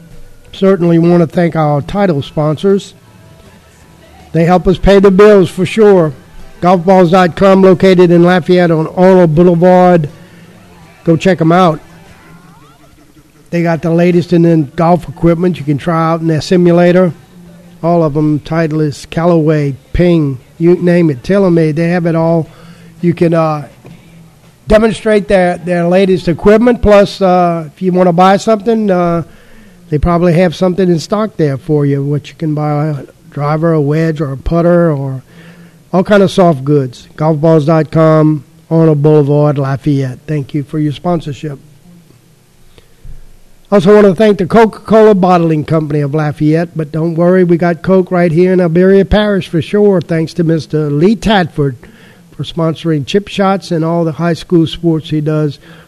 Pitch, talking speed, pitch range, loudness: 170 Hz, 160 wpm, 155-180 Hz, -10 LUFS